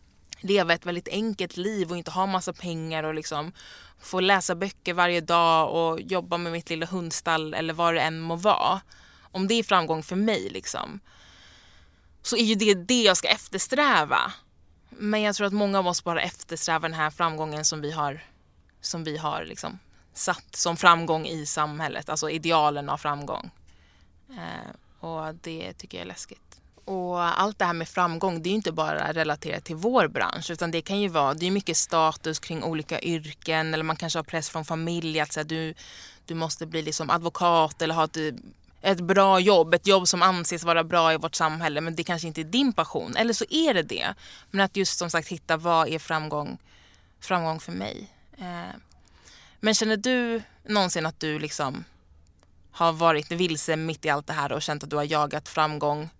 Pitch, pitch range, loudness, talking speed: 165 Hz, 155-180 Hz, -25 LUFS, 195 wpm